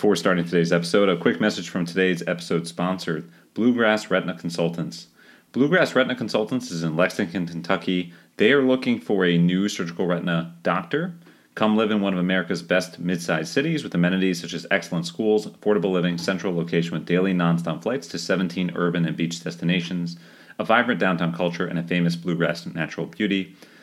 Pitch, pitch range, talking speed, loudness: 90 Hz, 85-100 Hz, 175 wpm, -23 LUFS